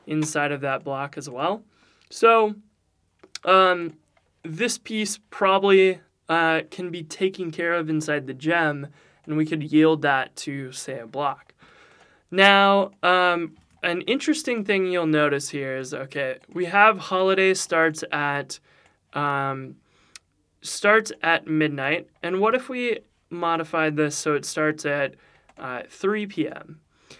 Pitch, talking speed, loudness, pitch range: 165 Hz, 135 wpm, -22 LUFS, 150-190 Hz